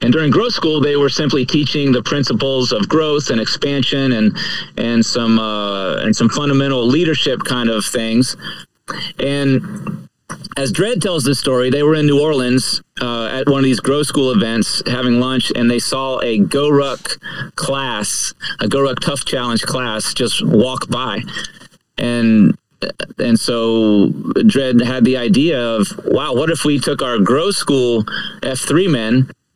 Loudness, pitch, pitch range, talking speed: -15 LUFS, 130 Hz, 120-145 Hz, 160 wpm